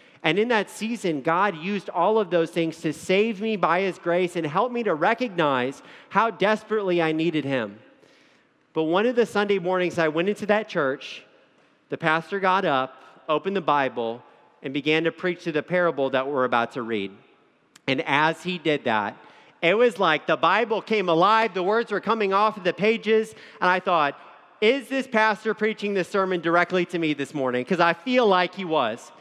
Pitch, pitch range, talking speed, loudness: 175 Hz, 155-210 Hz, 195 wpm, -23 LUFS